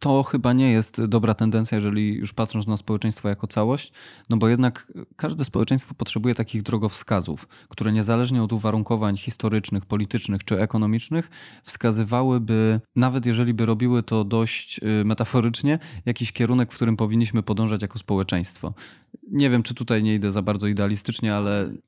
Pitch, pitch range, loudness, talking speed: 110 Hz, 105-120 Hz, -23 LUFS, 150 wpm